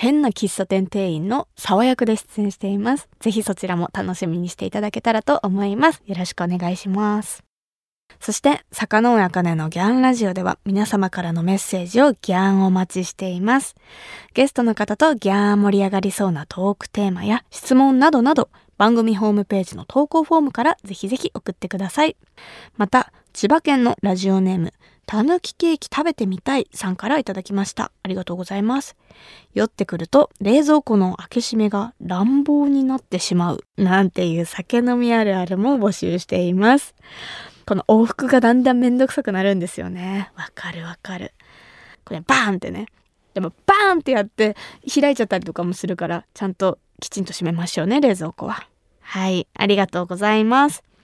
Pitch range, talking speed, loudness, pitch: 185-255 Hz, 385 characters per minute, -19 LUFS, 205 Hz